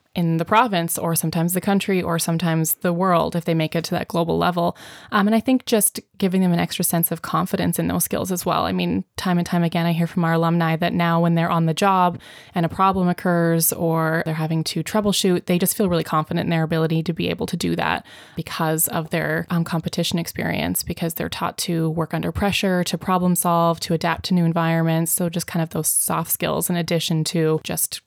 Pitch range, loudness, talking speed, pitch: 165-180 Hz, -21 LUFS, 235 wpm, 170 Hz